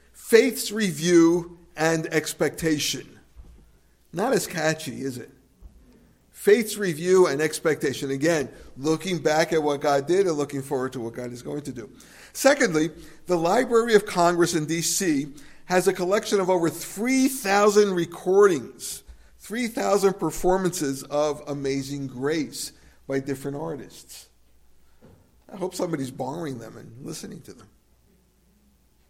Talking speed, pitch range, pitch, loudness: 125 wpm, 135-185 Hz, 160 Hz, -24 LUFS